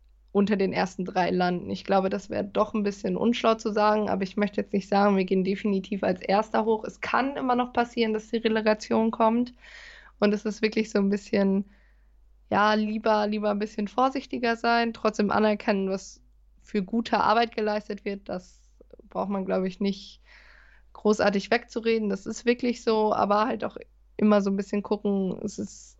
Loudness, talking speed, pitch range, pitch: -26 LUFS, 185 wpm, 200-225 Hz, 210 Hz